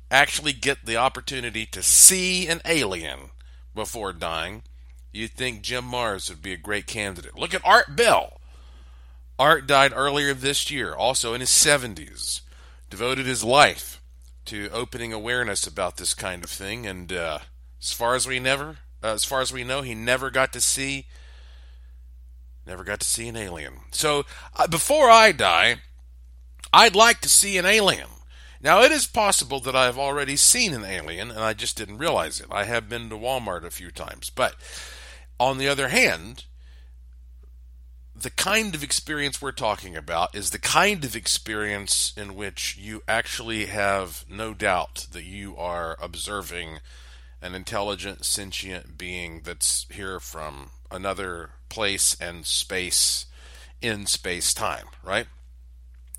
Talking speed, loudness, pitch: 155 wpm, -21 LUFS, 95 Hz